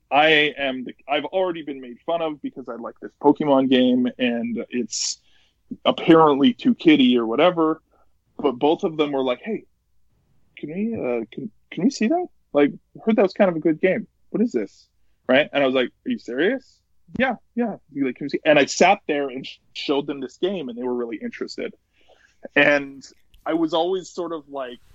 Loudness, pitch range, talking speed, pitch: -21 LUFS, 130-195 Hz, 190 wpm, 145 Hz